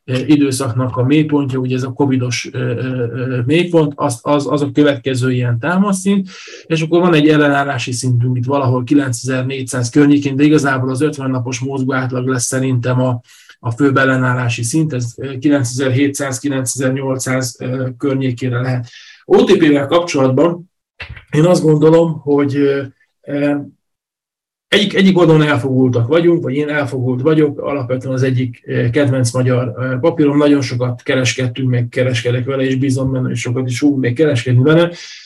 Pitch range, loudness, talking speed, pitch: 125-145 Hz, -15 LUFS, 135 wpm, 135 Hz